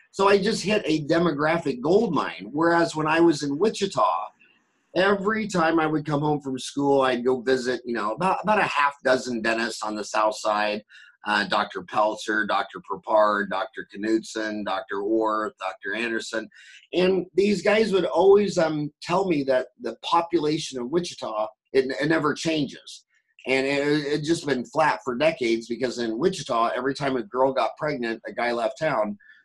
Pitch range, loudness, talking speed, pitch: 120-170 Hz, -24 LUFS, 175 wpm, 145 Hz